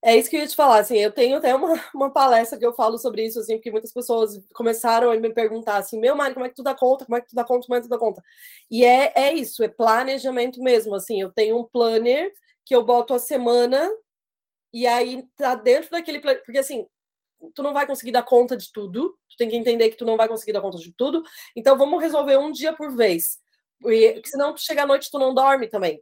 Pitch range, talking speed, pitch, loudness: 230-280 Hz, 255 wpm, 245 Hz, -21 LUFS